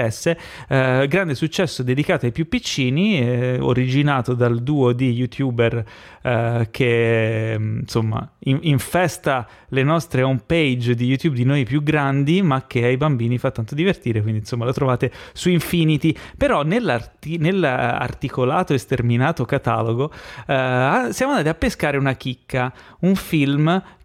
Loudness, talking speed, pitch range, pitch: -20 LUFS, 140 wpm, 125-155 Hz, 135 Hz